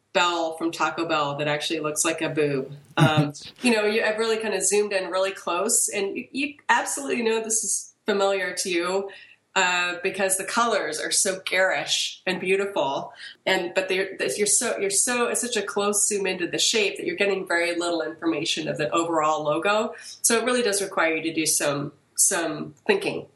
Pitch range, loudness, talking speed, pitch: 160-205 Hz, -23 LUFS, 195 wpm, 190 Hz